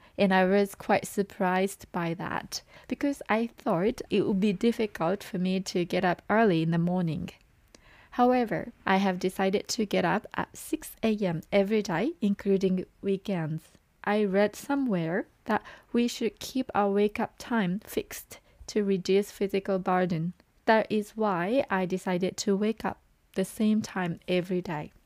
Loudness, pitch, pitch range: -28 LUFS, 200 Hz, 185-215 Hz